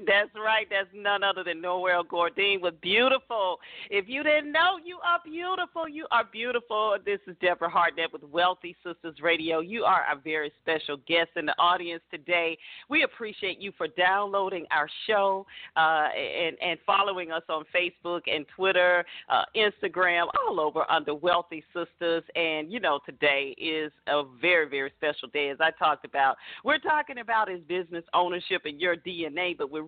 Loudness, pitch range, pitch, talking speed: -27 LUFS, 165-205 Hz, 175 Hz, 175 wpm